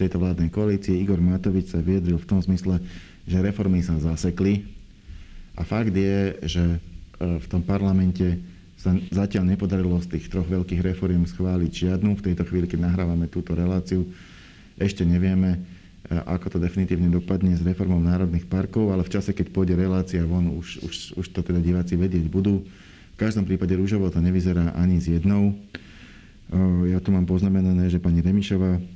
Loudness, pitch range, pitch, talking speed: -23 LUFS, 85-95 Hz, 90 Hz, 165 wpm